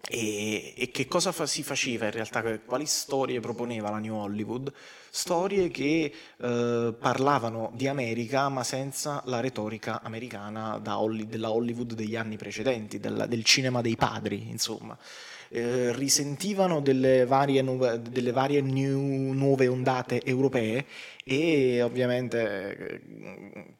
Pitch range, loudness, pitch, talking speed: 115-135 Hz, -28 LUFS, 125 Hz, 135 wpm